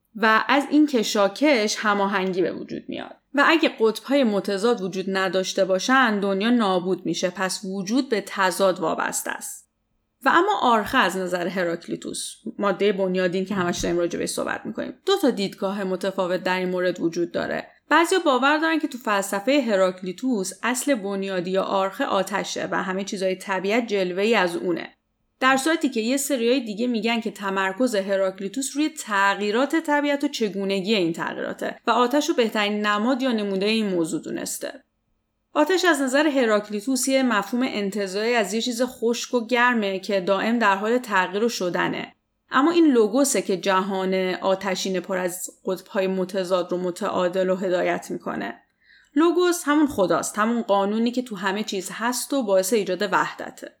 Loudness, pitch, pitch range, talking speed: -23 LUFS, 205 Hz, 190-255 Hz, 160 wpm